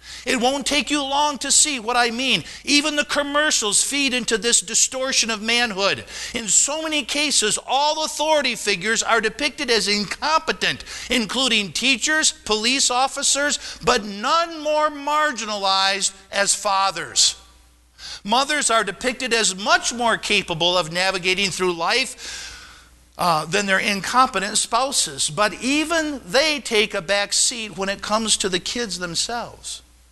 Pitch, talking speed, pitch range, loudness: 235 Hz, 140 wpm, 200-285 Hz, -19 LUFS